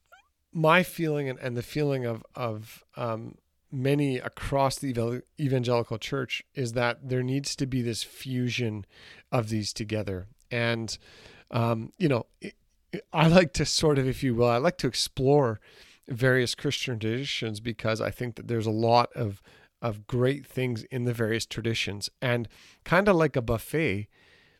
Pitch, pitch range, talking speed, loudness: 120 Hz, 115-135 Hz, 155 wpm, -27 LUFS